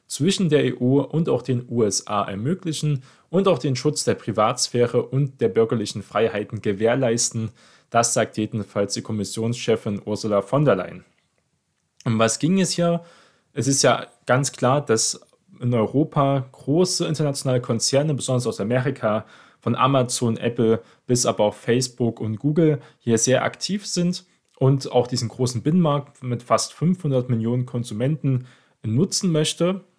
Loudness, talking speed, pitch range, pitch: -22 LUFS, 145 wpm, 115-145 Hz, 125 Hz